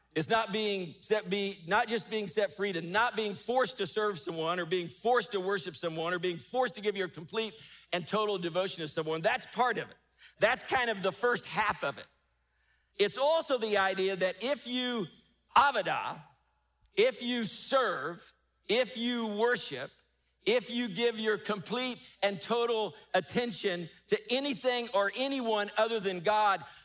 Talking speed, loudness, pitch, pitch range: 170 wpm, -31 LUFS, 210 Hz, 185-235 Hz